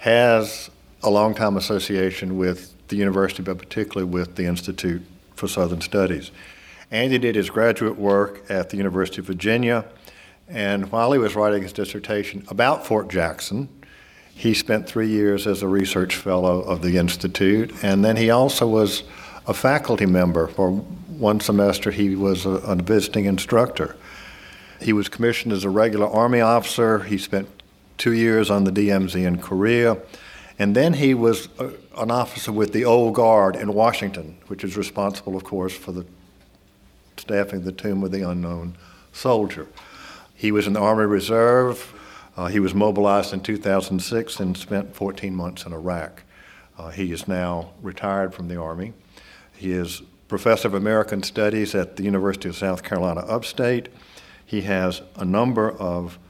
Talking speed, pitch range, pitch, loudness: 165 wpm, 95-110 Hz, 100 Hz, -21 LUFS